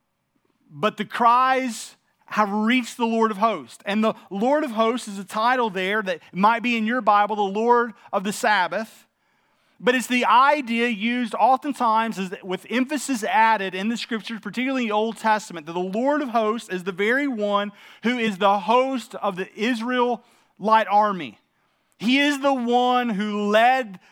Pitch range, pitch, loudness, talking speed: 205-245 Hz, 225 Hz, -22 LUFS, 170 wpm